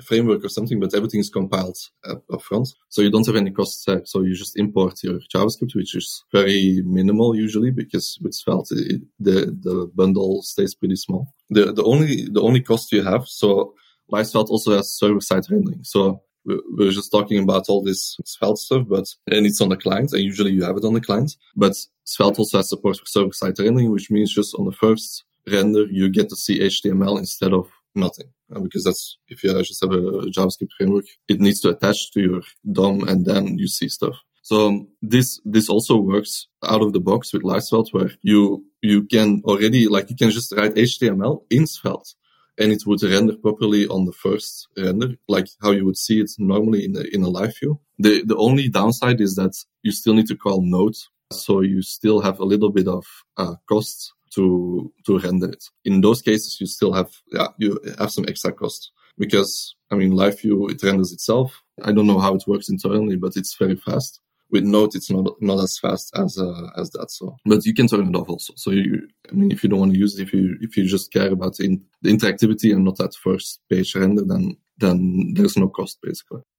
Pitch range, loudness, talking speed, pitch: 95-110 Hz, -20 LUFS, 215 wpm, 100 Hz